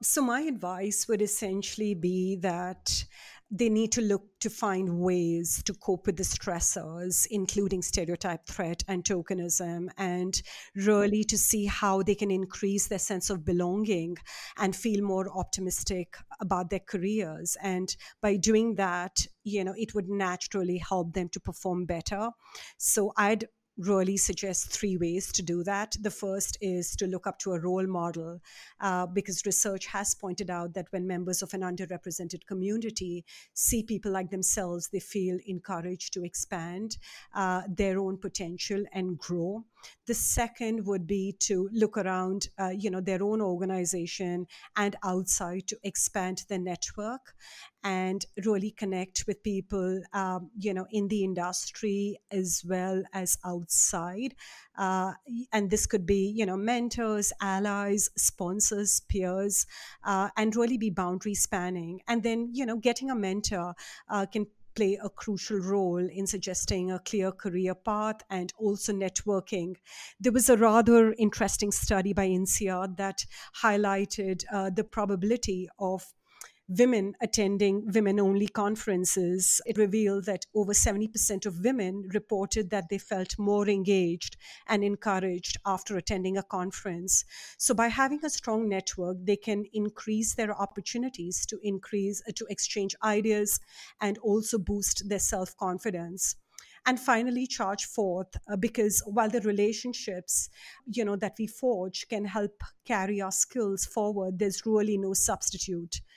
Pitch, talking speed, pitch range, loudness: 200 Hz, 145 wpm, 185-210 Hz, -29 LUFS